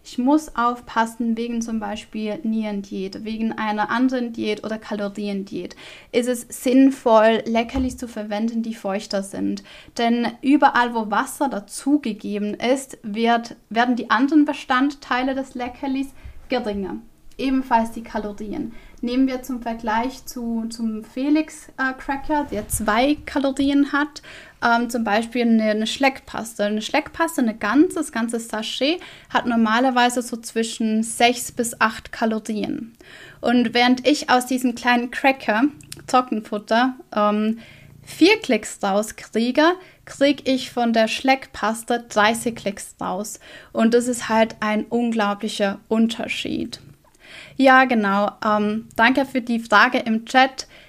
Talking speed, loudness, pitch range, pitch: 125 wpm, -21 LUFS, 220-265 Hz, 235 Hz